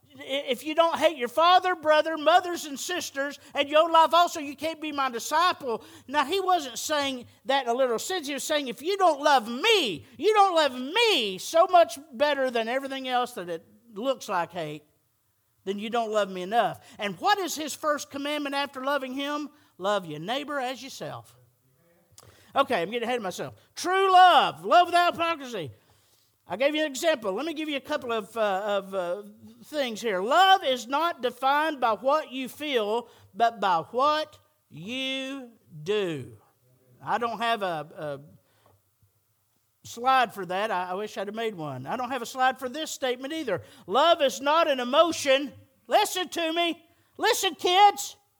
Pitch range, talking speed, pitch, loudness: 205-310 Hz, 180 wpm, 265 Hz, -25 LUFS